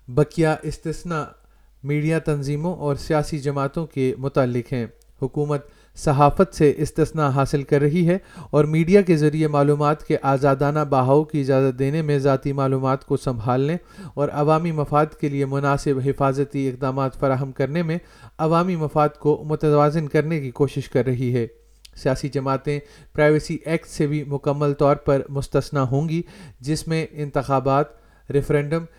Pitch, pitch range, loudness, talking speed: 145 Hz, 135-155 Hz, -21 LUFS, 145 wpm